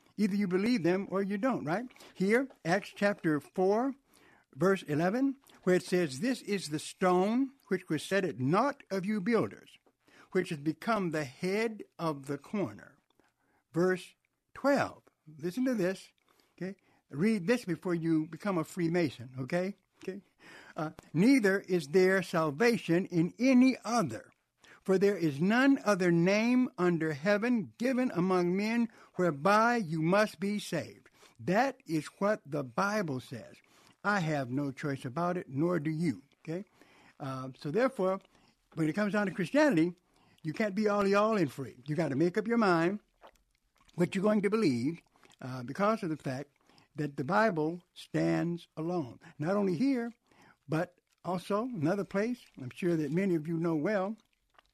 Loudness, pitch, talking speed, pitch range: -31 LUFS, 185 Hz, 160 wpm, 160-210 Hz